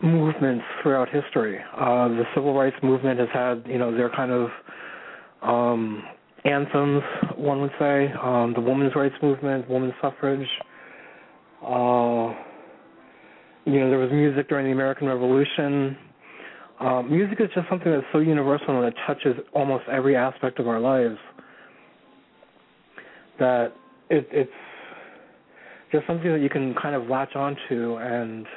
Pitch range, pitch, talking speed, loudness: 125-145 Hz, 135 Hz, 140 wpm, -24 LUFS